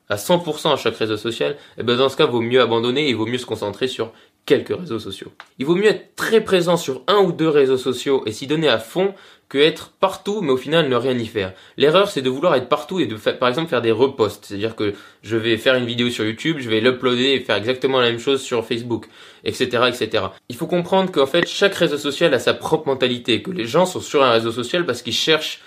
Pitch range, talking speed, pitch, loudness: 120-165 Hz, 260 wpm, 130 Hz, -19 LUFS